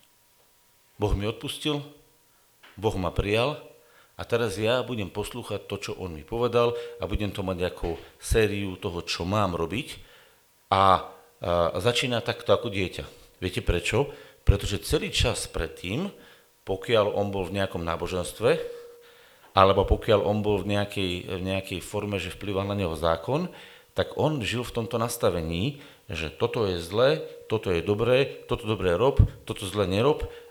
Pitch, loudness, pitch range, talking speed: 105 Hz, -27 LUFS, 95-125 Hz, 150 wpm